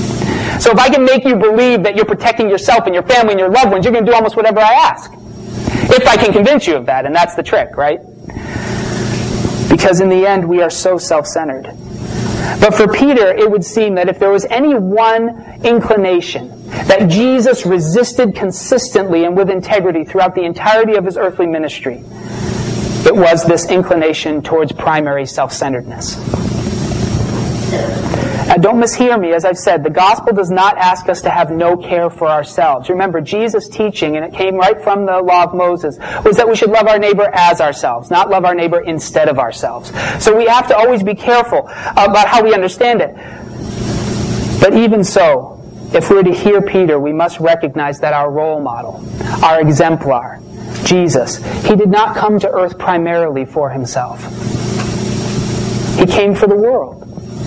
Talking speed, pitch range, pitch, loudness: 180 wpm, 170-220 Hz, 190 Hz, -12 LUFS